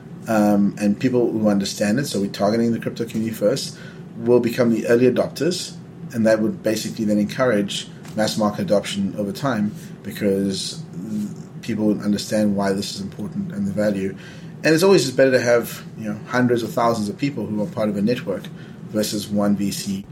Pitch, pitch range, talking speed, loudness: 120 Hz, 105-175 Hz, 185 wpm, -21 LUFS